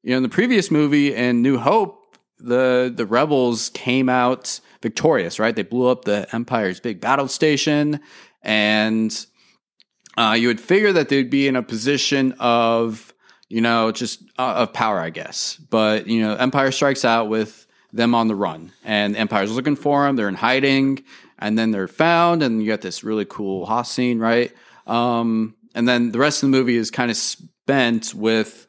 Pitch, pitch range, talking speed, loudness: 120 Hz, 110-135 Hz, 185 wpm, -19 LUFS